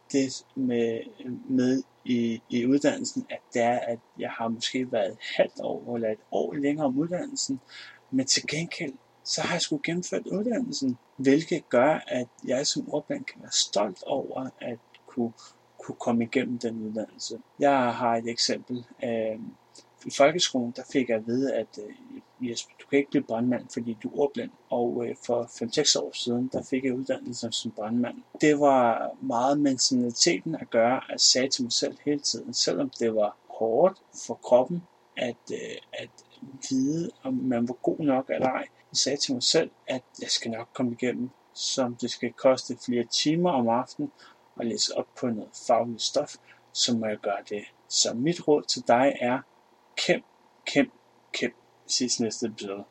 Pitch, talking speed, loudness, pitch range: 125 Hz, 180 wpm, -27 LUFS, 120-145 Hz